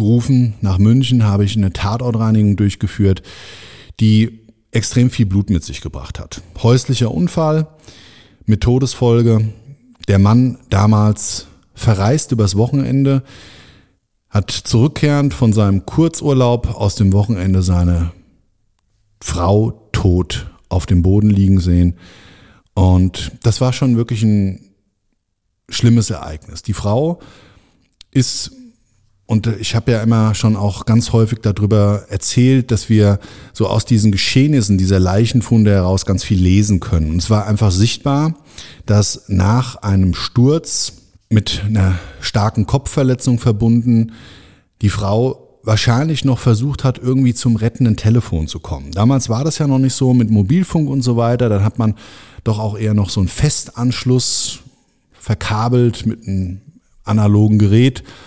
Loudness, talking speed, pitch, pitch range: -15 LUFS, 135 wpm, 110 Hz, 100-120 Hz